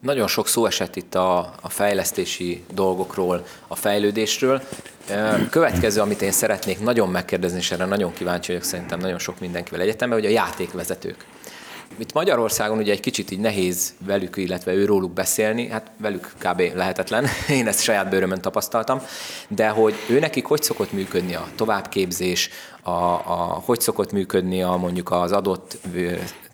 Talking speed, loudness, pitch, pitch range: 160 wpm, -22 LUFS, 95 Hz, 90-105 Hz